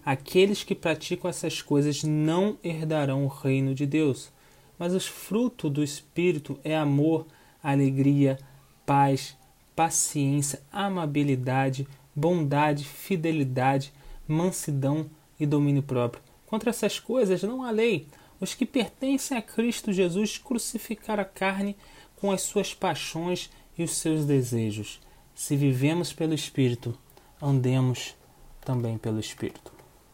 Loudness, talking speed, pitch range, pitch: -27 LUFS, 115 wpm, 140-185 Hz, 155 Hz